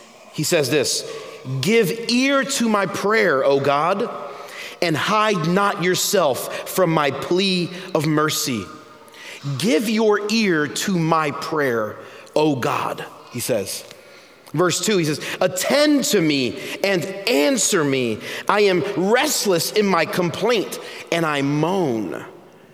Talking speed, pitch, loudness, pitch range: 125 wpm, 185 Hz, -19 LUFS, 155-220 Hz